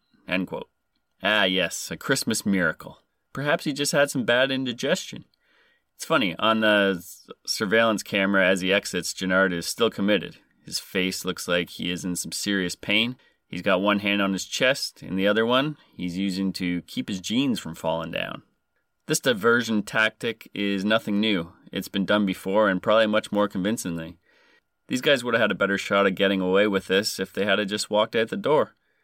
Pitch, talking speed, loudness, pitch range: 100 Hz, 190 wpm, -24 LUFS, 95-110 Hz